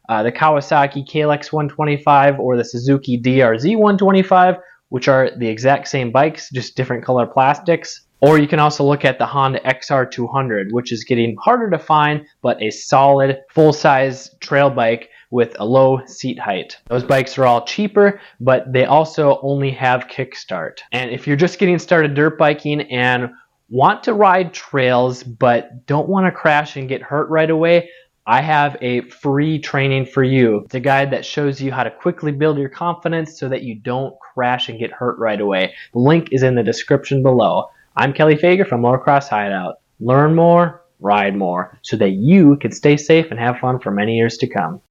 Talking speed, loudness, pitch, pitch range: 190 wpm, -16 LUFS, 135 Hz, 125-155 Hz